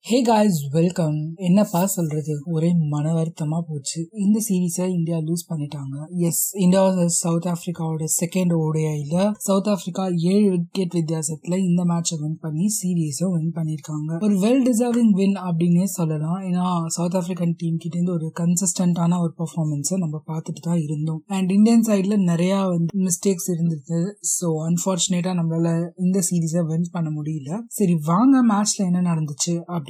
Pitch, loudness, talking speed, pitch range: 175 Hz, -21 LUFS, 120 wpm, 165-190 Hz